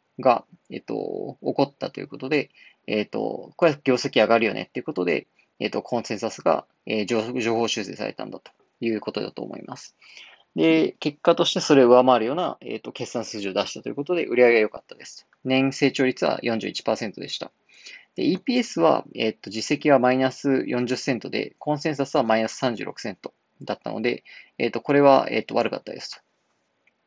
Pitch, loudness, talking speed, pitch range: 125 Hz, -23 LUFS, 375 characters per minute, 110-140 Hz